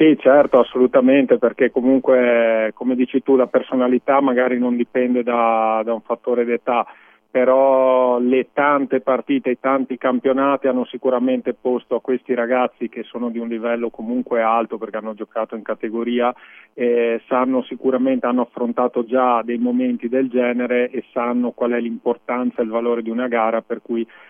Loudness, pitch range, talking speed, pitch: -19 LUFS, 120-130 Hz, 165 wpm, 125 Hz